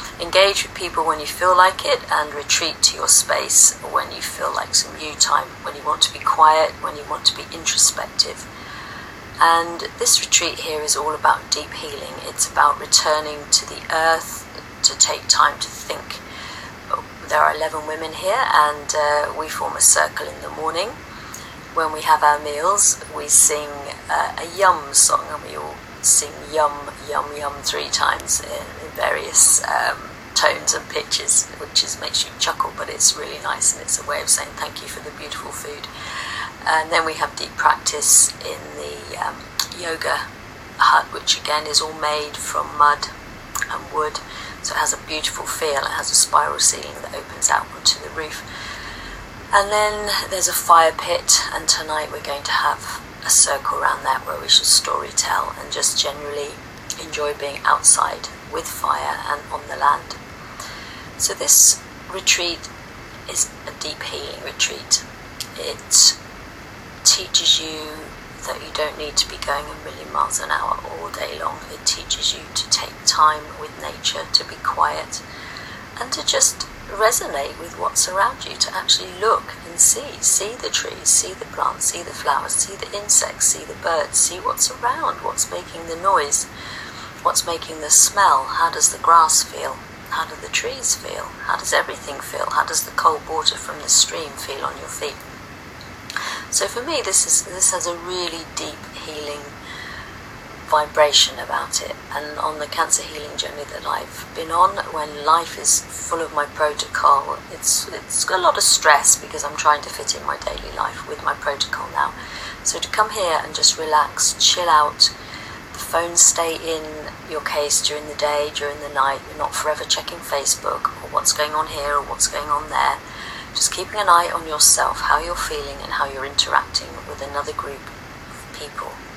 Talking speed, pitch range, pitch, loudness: 180 wpm, 145-165 Hz, 150 Hz, -18 LUFS